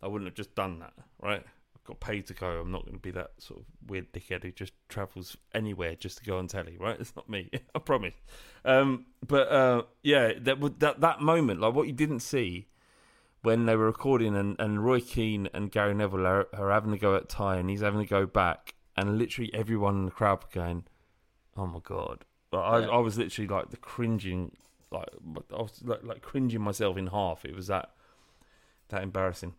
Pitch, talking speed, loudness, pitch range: 100 Hz, 215 wpm, -30 LUFS, 95-115 Hz